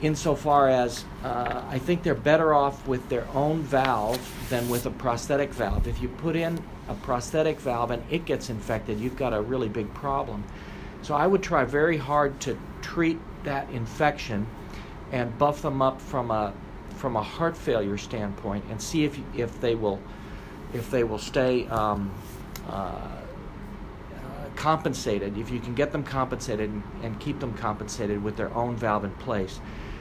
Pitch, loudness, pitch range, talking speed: 125 Hz, -27 LUFS, 105-145 Hz, 175 wpm